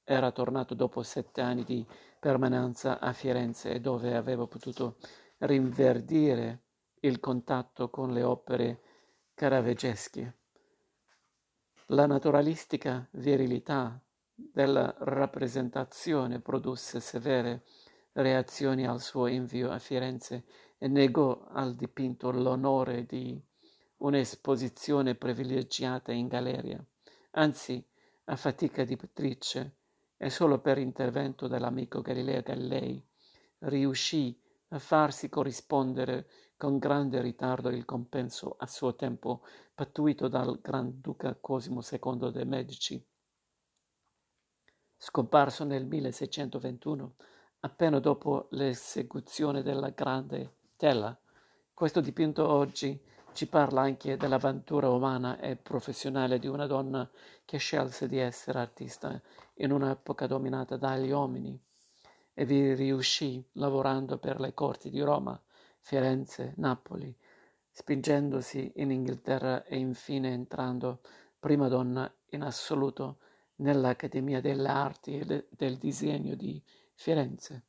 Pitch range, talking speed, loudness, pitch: 125-140 Hz, 105 wpm, -32 LUFS, 130 Hz